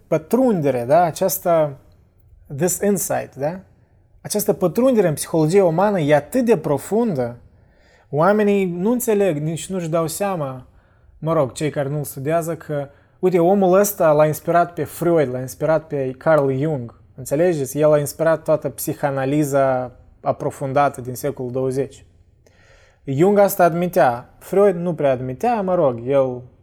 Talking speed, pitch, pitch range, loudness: 135 wpm, 150 Hz, 130-180 Hz, -19 LUFS